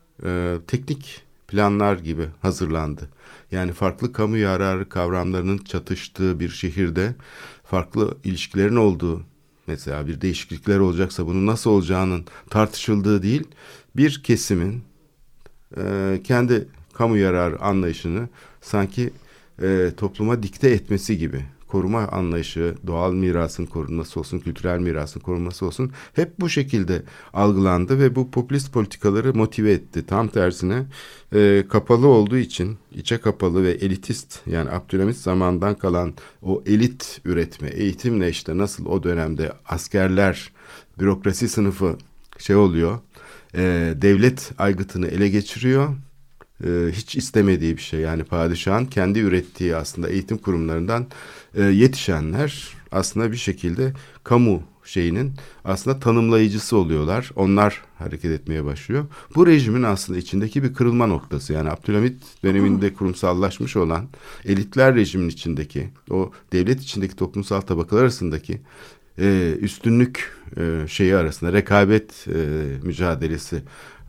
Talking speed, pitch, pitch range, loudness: 110 wpm, 95 Hz, 90-115 Hz, -21 LUFS